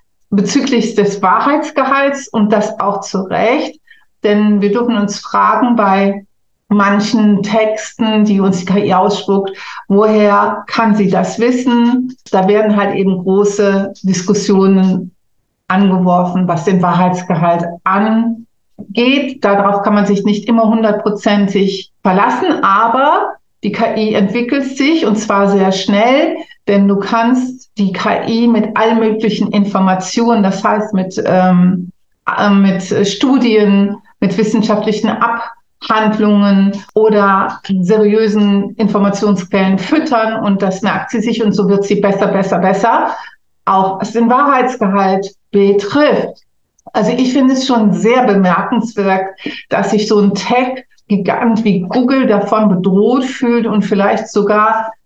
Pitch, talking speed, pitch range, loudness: 210 Hz, 125 wpm, 195-230 Hz, -12 LUFS